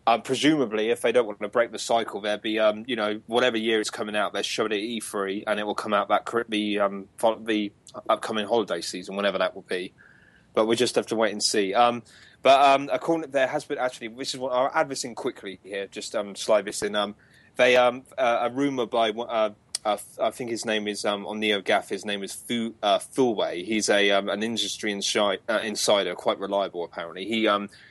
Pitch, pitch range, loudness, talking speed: 110 Hz, 105-125 Hz, -25 LUFS, 240 wpm